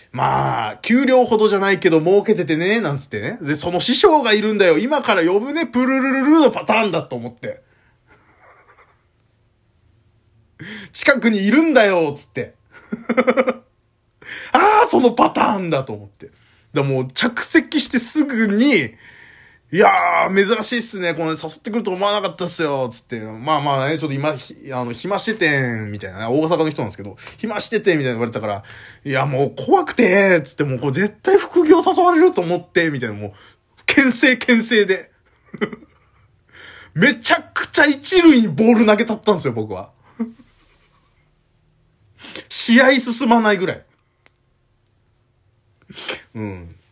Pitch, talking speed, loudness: 180 Hz, 305 characters per minute, -16 LUFS